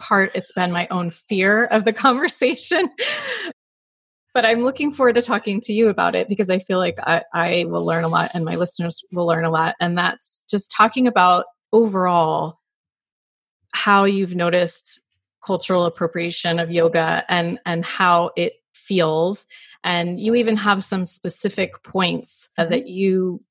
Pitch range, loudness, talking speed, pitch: 170-220 Hz, -19 LUFS, 160 wpm, 185 Hz